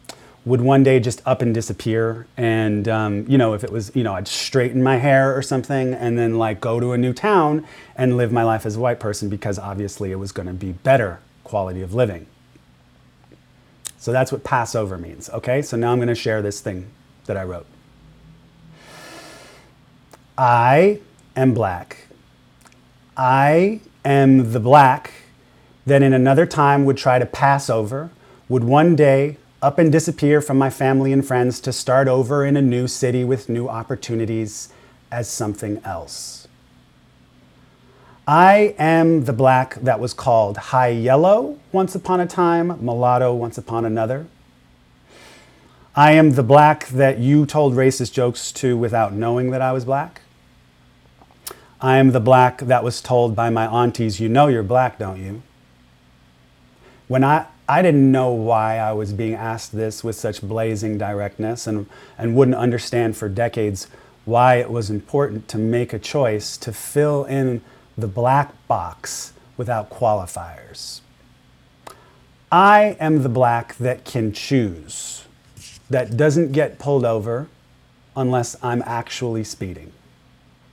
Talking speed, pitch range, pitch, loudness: 155 wpm, 110-135 Hz, 125 Hz, -18 LUFS